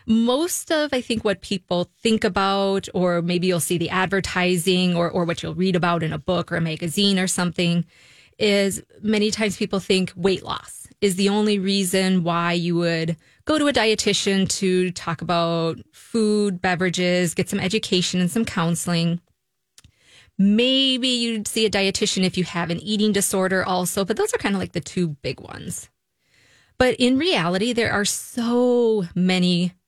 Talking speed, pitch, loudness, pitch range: 175 wpm, 190 Hz, -21 LUFS, 175-215 Hz